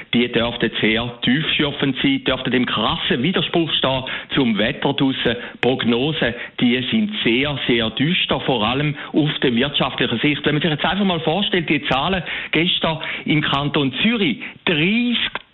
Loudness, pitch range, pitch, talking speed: -19 LUFS, 130-175 Hz, 150 Hz, 145 wpm